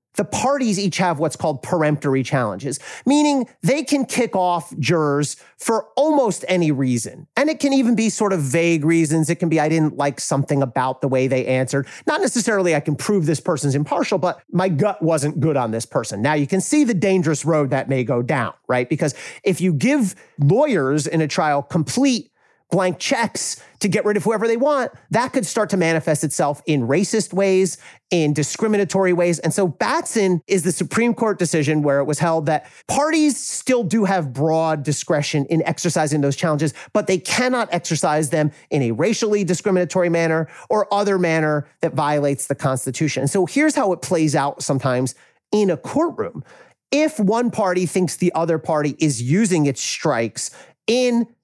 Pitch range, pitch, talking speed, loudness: 150-210 Hz, 170 Hz, 185 wpm, -19 LUFS